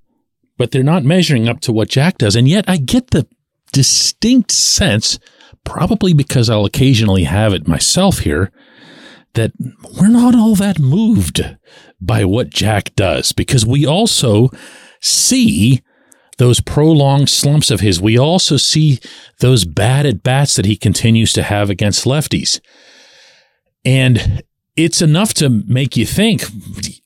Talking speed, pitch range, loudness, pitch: 140 wpm, 115-155 Hz, -12 LUFS, 130 Hz